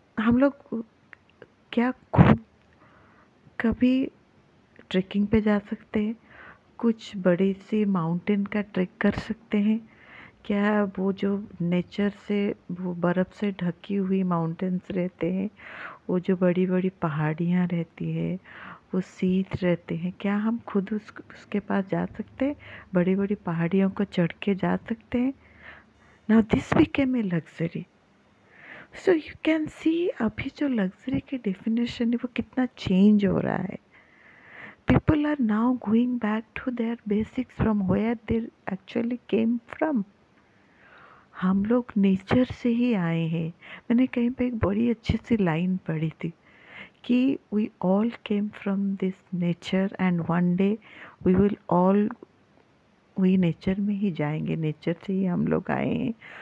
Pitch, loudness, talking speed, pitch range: 205 Hz, -26 LUFS, 145 wpm, 185-230 Hz